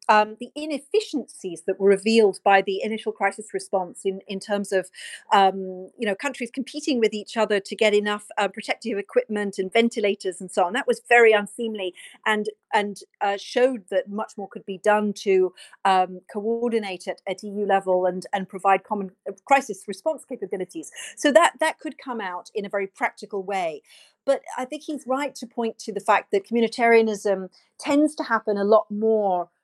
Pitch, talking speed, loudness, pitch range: 210 Hz, 185 wpm, -23 LUFS, 195-245 Hz